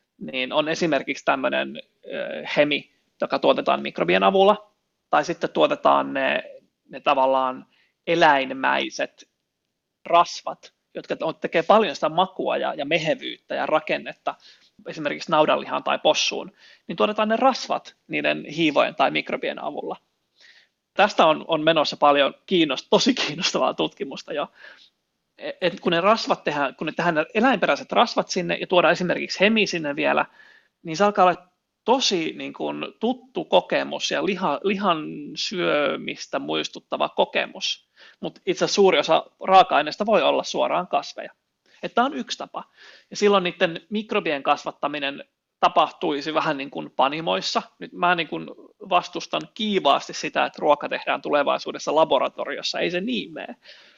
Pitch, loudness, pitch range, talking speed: 180 Hz, -22 LUFS, 150-210 Hz, 135 wpm